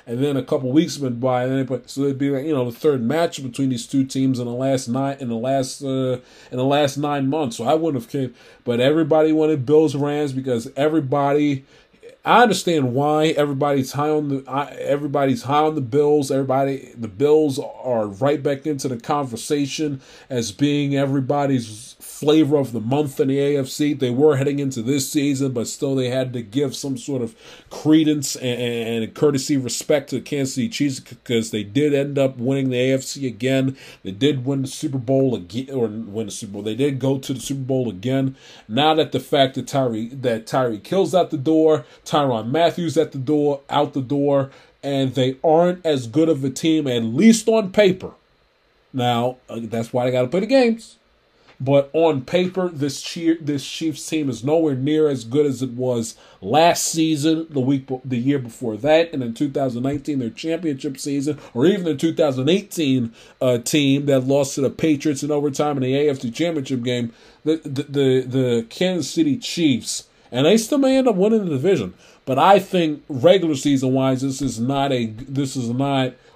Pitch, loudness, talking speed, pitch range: 140 Hz, -20 LUFS, 200 wpm, 130-150 Hz